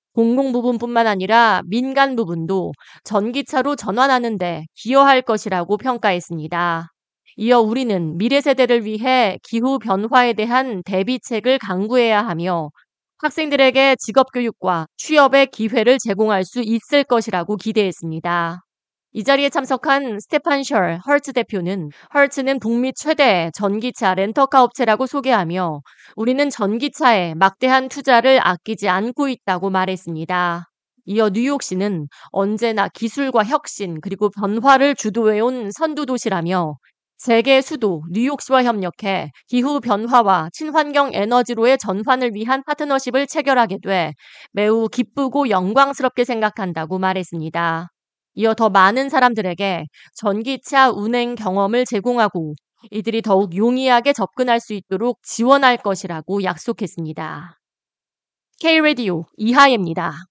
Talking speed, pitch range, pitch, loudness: 310 characters per minute, 190-260 Hz, 225 Hz, -18 LUFS